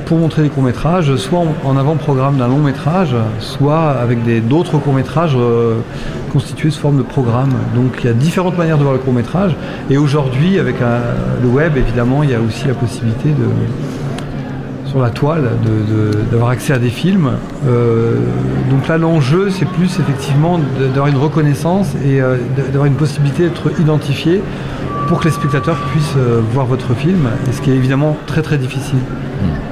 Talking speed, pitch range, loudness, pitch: 180 wpm, 125-155 Hz, -14 LUFS, 140 Hz